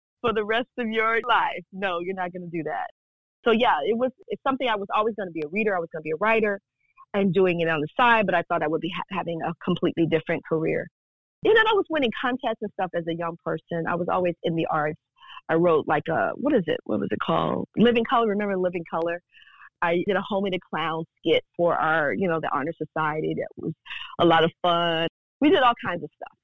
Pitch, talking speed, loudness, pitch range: 185 Hz, 250 wpm, -24 LUFS, 165-225 Hz